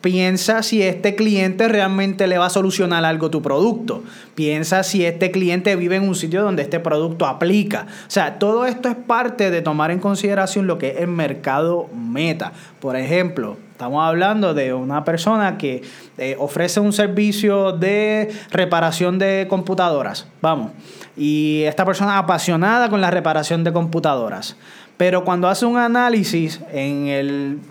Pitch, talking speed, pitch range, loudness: 185 Hz, 160 wpm, 160-200 Hz, -18 LUFS